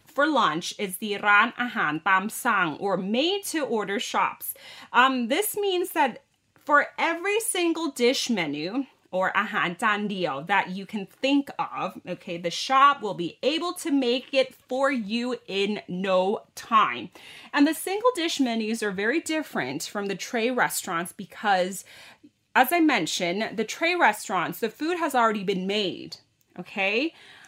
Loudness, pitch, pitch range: -25 LUFS, 235 Hz, 195-290 Hz